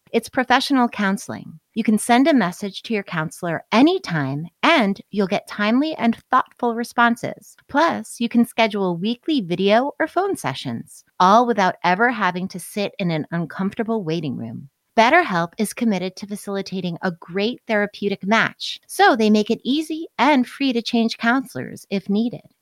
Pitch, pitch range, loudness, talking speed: 220 Hz, 190-245 Hz, -20 LUFS, 160 wpm